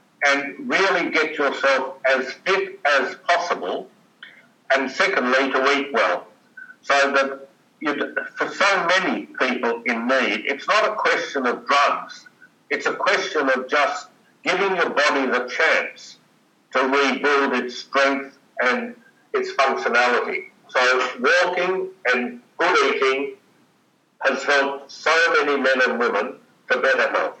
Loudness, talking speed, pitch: -20 LUFS, 130 wpm, 145 Hz